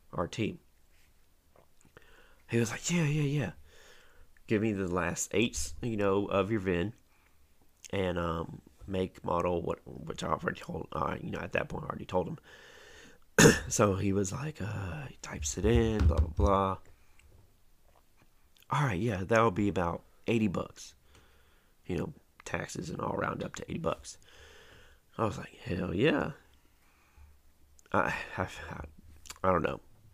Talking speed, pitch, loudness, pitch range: 155 wpm, 90 Hz, -32 LUFS, 80-100 Hz